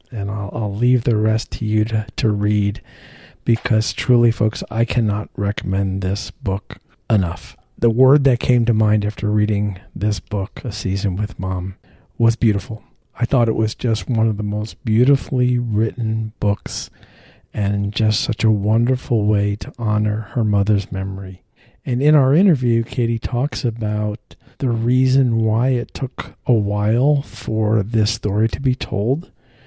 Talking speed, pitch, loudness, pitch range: 160 wpm, 110 Hz, -19 LUFS, 105-120 Hz